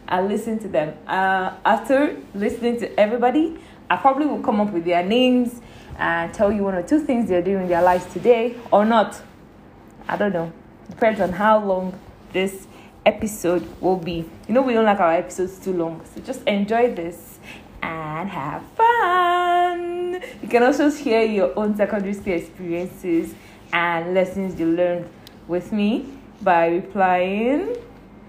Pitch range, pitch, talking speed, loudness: 180-240 Hz, 200 Hz, 160 wpm, -21 LUFS